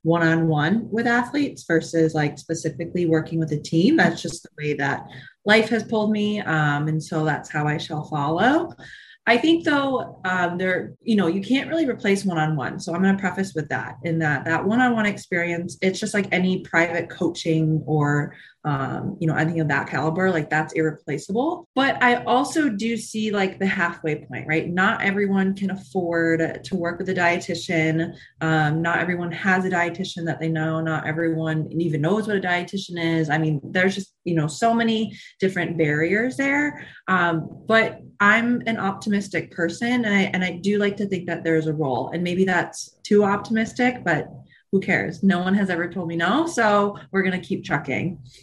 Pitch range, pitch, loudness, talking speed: 160-205 Hz, 175 Hz, -22 LUFS, 190 wpm